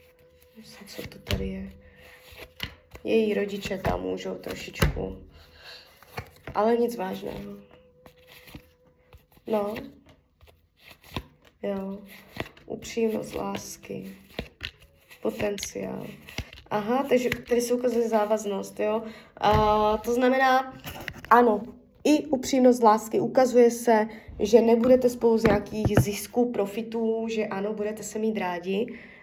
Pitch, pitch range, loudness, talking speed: 215 Hz, 185-235 Hz, -25 LUFS, 95 wpm